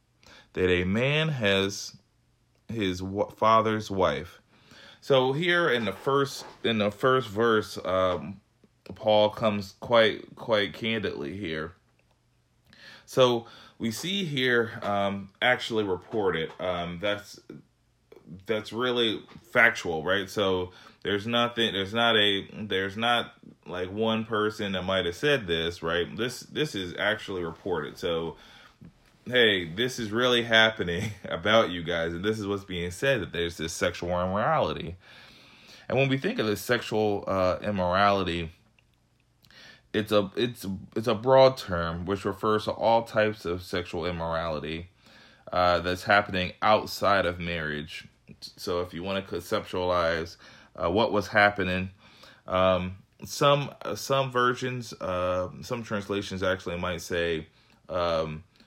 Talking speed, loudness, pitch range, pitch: 135 wpm, -27 LUFS, 90-115 Hz, 105 Hz